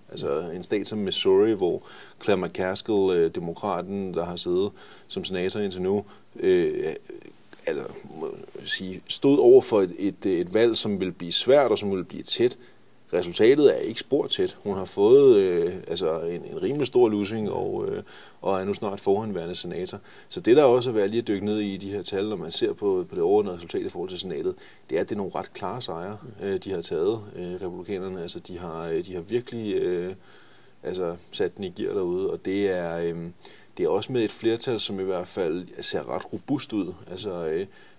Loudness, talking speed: -25 LUFS, 210 wpm